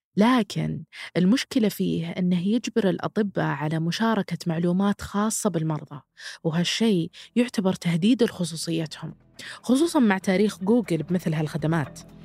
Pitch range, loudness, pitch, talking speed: 165-215 Hz, -24 LUFS, 185 Hz, 105 wpm